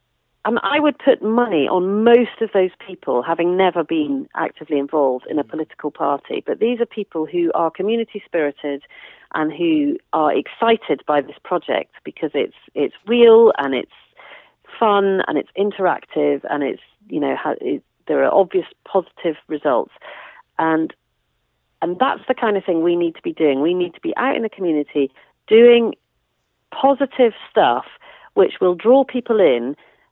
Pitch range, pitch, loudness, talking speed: 155-230 Hz, 185 Hz, -18 LUFS, 165 wpm